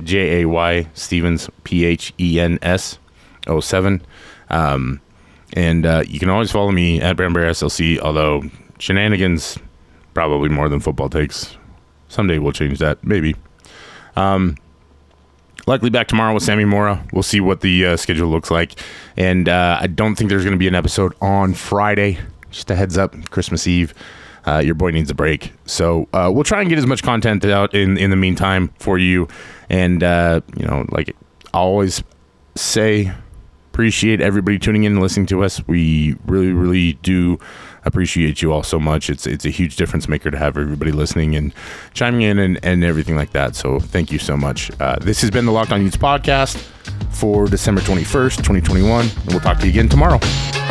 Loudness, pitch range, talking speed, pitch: -17 LUFS, 80-100 Hz, 180 wpm, 90 Hz